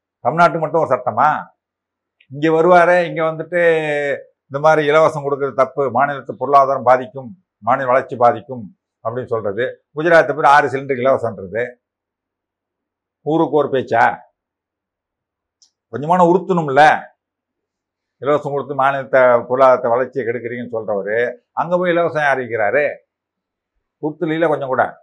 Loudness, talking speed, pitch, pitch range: -16 LUFS, 110 wpm, 140 Hz, 120-165 Hz